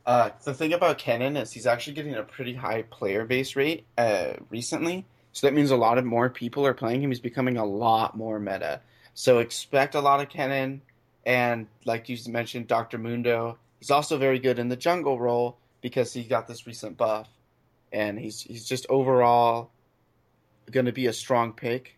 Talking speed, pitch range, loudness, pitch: 195 wpm, 115-135 Hz, -26 LUFS, 120 Hz